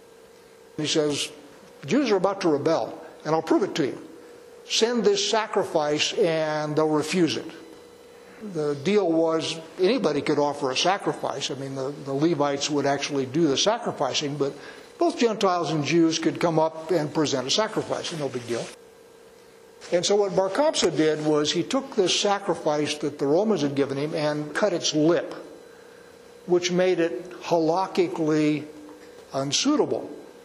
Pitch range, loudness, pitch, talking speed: 150-220 Hz, -24 LUFS, 165 Hz, 155 wpm